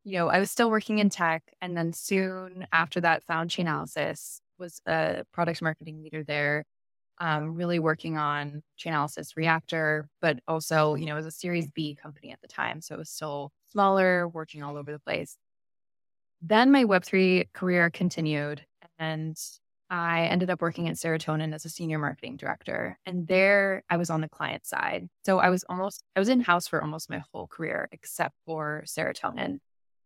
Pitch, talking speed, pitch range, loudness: 165 Hz, 180 wpm, 155-180 Hz, -28 LUFS